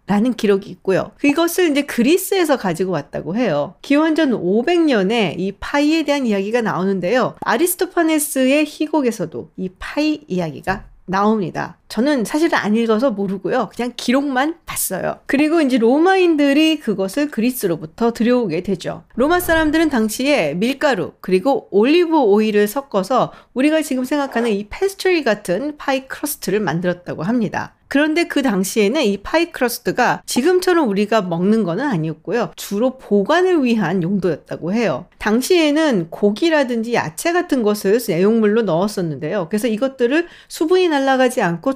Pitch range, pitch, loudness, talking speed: 200-300 Hz, 240 Hz, -17 LUFS, 370 characters per minute